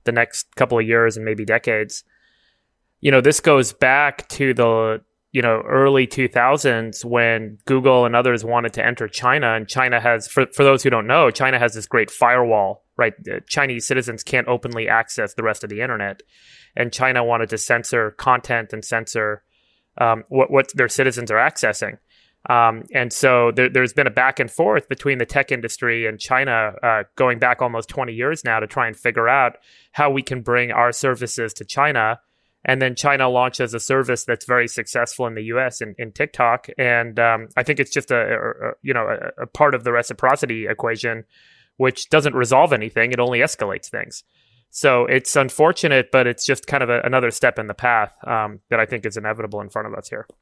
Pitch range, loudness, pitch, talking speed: 115-130 Hz, -18 LUFS, 120 Hz, 200 wpm